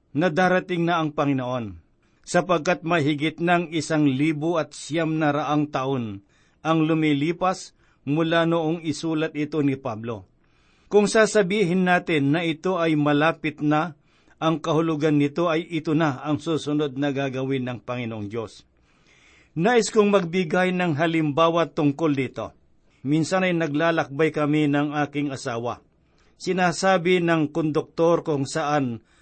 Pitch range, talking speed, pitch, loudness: 145-170 Hz, 125 wpm, 155 Hz, -23 LUFS